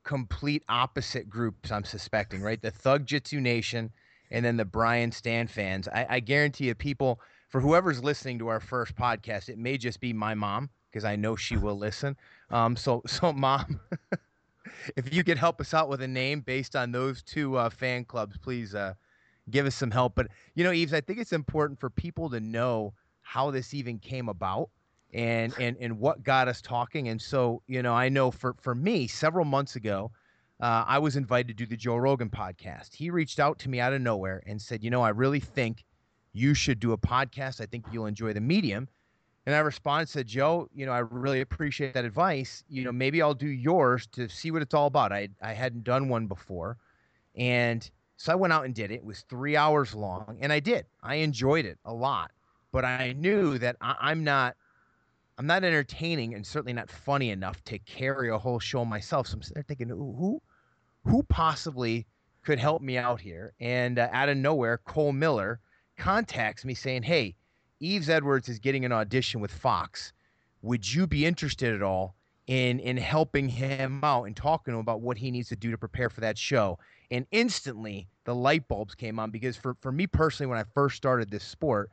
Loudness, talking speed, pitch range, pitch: -29 LUFS, 210 wpm, 115-140 Hz, 125 Hz